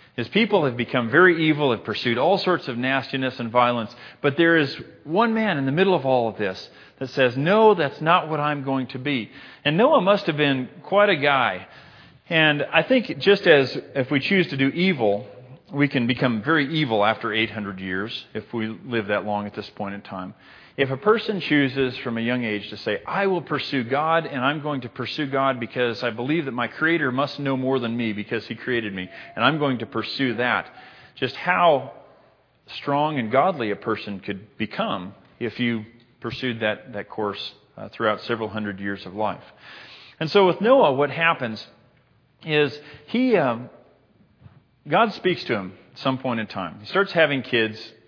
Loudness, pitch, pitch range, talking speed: -22 LUFS, 130 Hz, 115-155 Hz, 195 wpm